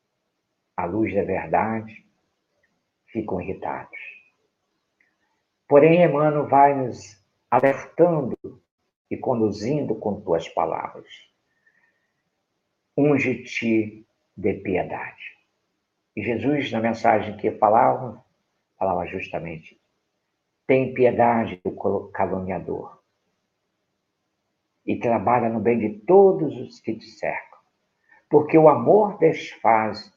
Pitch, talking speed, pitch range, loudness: 120 Hz, 90 wpm, 110-145 Hz, -21 LUFS